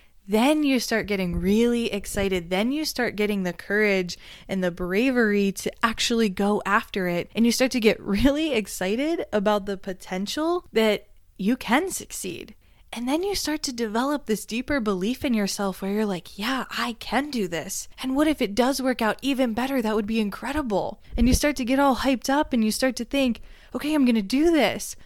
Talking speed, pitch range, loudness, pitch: 205 wpm, 205-265 Hz, -24 LUFS, 230 Hz